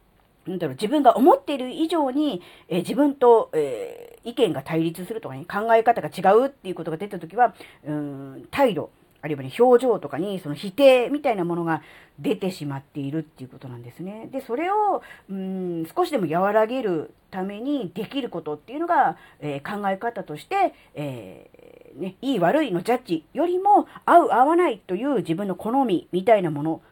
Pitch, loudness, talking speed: 205 Hz, -23 LUFS, 355 characters per minute